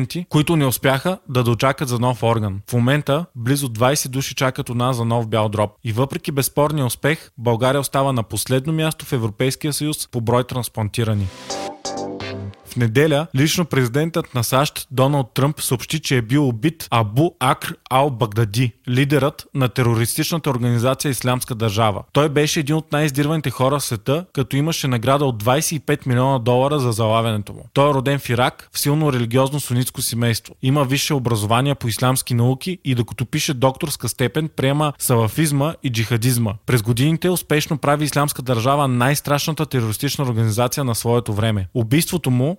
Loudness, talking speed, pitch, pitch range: -19 LUFS, 160 wpm, 130 Hz, 120-145 Hz